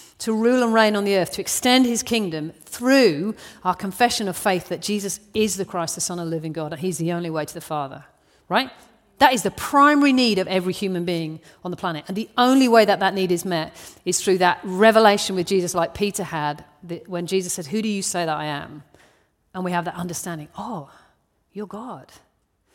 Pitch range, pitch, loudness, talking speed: 170-210 Hz, 185 Hz, -21 LUFS, 220 wpm